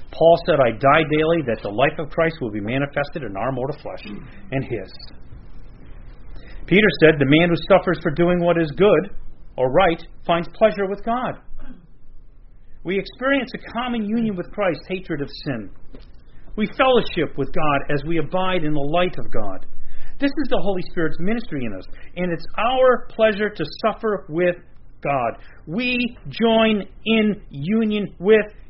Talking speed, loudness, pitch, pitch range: 165 wpm, -20 LUFS, 170 Hz, 140-210 Hz